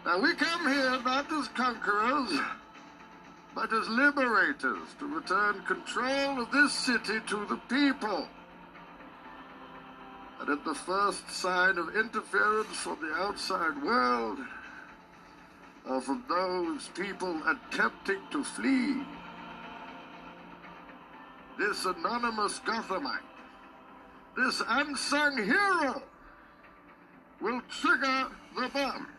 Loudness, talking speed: -30 LUFS, 95 wpm